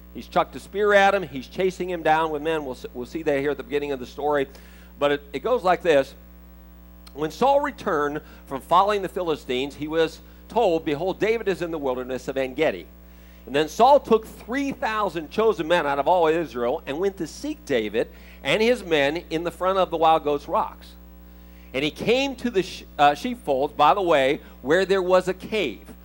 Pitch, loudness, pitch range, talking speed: 155 Hz, -23 LUFS, 130-185 Hz, 210 wpm